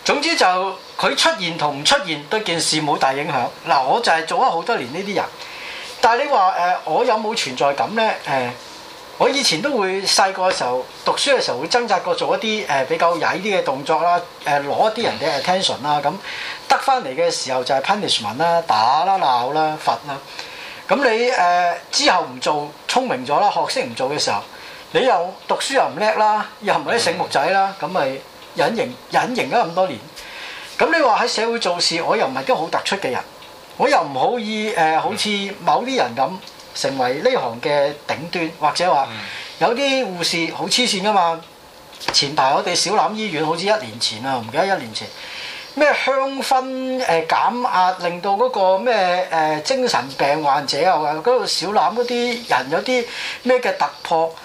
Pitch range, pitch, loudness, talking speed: 165-255 Hz, 195 Hz, -18 LUFS, 305 characters per minute